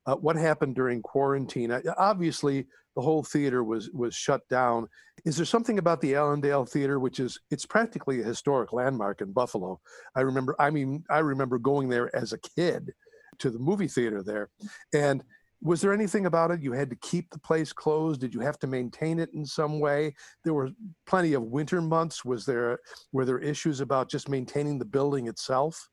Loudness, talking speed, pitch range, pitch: -28 LUFS, 195 wpm, 130-160 Hz, 145 Hz